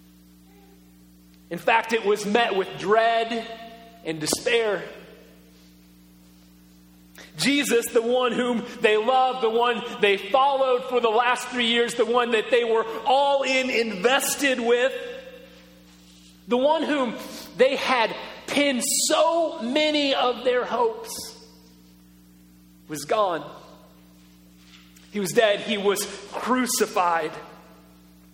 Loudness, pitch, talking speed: -22 LUFS, 225 Hz, 110 wpm